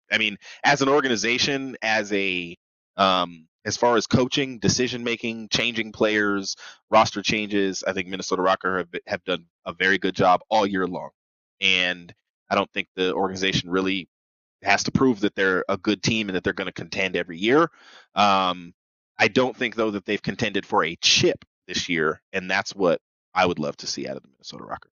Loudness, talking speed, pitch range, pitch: -23 LUFS, 195 wpm, 90-115 Hz, 100 Hz